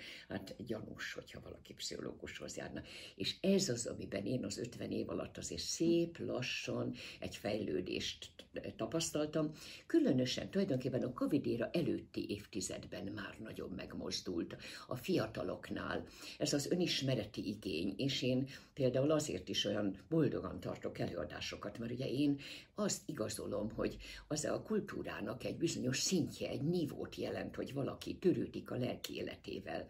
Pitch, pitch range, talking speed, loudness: 130 Hz, 105-150 Hz, 130 wpm, -39 LUFS